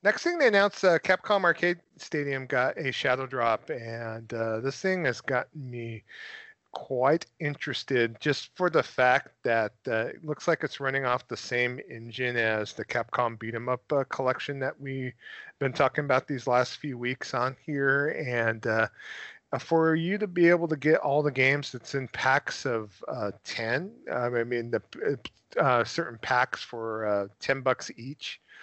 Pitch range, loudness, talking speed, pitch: 120-150 Hz, -28 LUFS, 175 wpm, 130 Hz